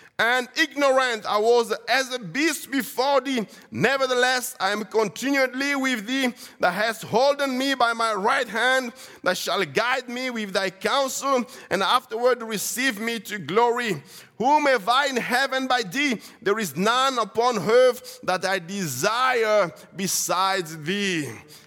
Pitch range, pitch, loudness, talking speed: 210-260 Hz, 245 Hz, -23 LUFS, 145 wpm